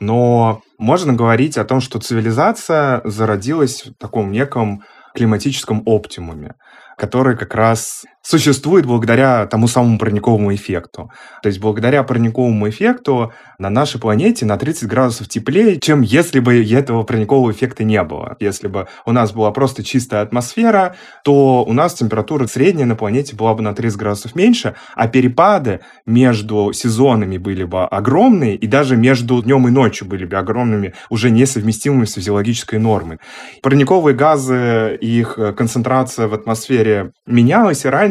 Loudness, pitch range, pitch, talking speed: -15 LUFS, 110-130 Hz, 115 Hz, 145 wpm